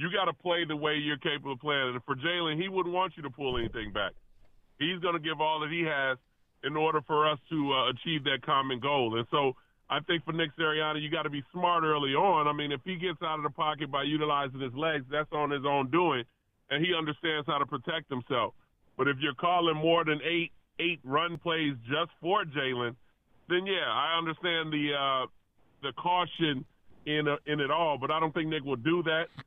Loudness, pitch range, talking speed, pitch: -30 LUFS, 140-165 Hz, 230 wpm, 155 Hz